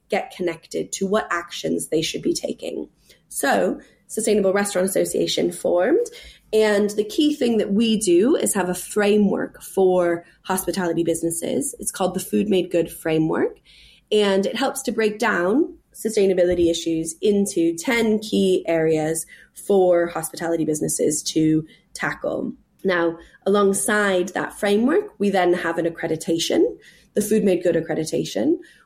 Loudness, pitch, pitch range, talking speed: -21 LUFS, 190 Hz, 170-220 Hz, 135 wpm